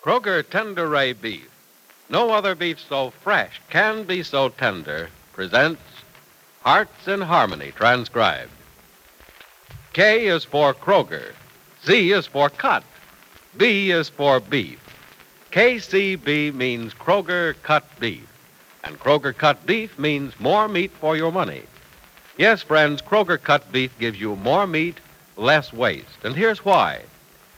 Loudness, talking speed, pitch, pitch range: -20 LUFS, 130 wpm, 155 Hz, 135-190 Hz